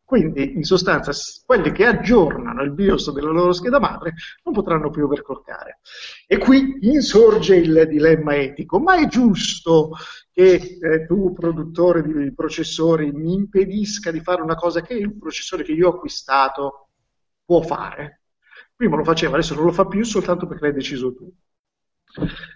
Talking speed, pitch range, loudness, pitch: 155 wpm, 155-195 Hz, -18 LUFS, 170 Hz